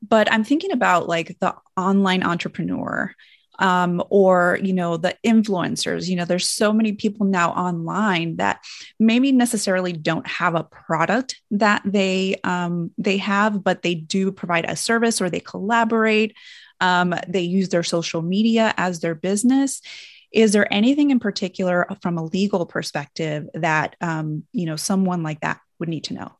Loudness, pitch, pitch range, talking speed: -20 LUFS, 190 Hz, 175-215 Hz, 165 wpm